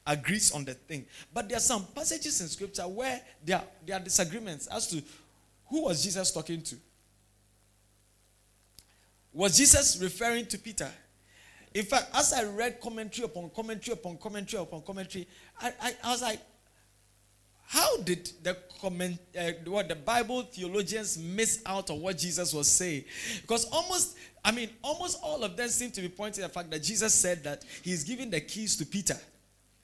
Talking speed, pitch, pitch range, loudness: 170 wpm, 185 Hz, 155-225 Hz, -29 LUFS